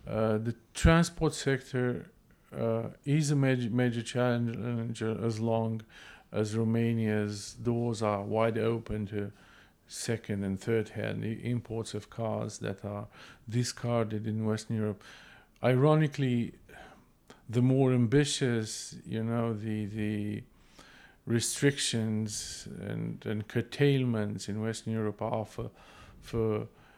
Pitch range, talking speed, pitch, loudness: 110-120 Hz, 110 wpm, 115 Hz, -31 LUFS